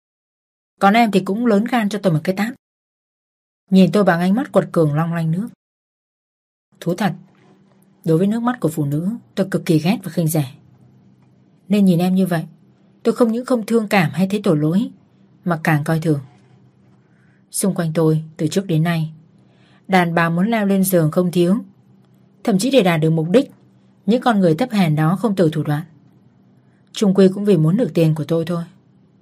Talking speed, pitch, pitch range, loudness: 200 wpm, 180 Hz, 160-200 Hz, -18 LUFS